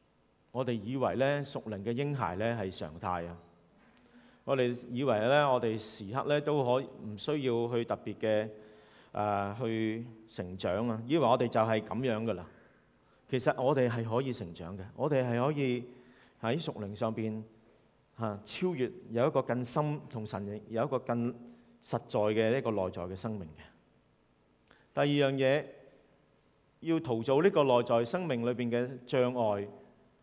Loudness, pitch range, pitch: -32 LUFS, 105-130 Hz, 115 Hz